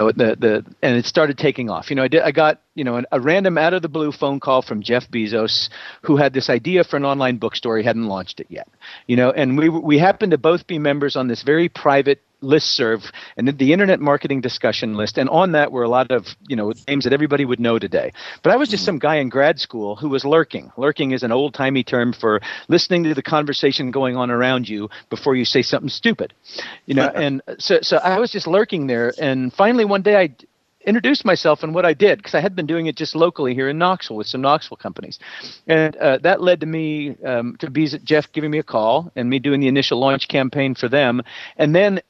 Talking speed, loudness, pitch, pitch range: 240 wpm, -18 LUFS, 140 Hz, 125-160 Hz